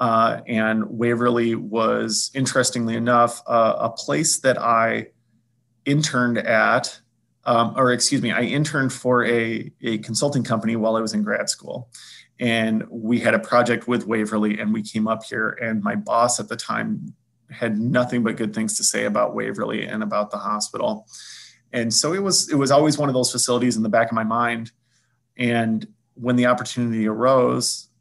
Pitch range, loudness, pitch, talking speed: 115-125 Hz, -21 LUFS, 120 Hz, 180 wpm